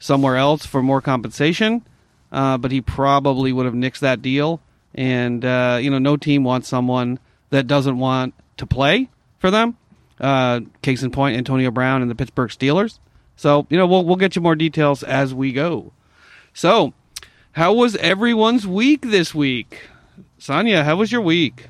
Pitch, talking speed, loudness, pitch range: 135 Hz, 175 wpm, -18 LUFS, 130-160 Hz